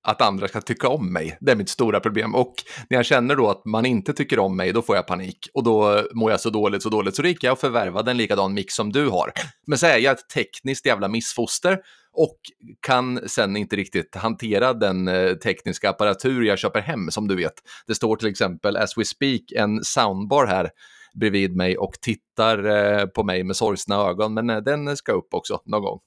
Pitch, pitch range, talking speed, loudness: 110 Hz, 100-120 Hz, 220 wpm, -22 LUFS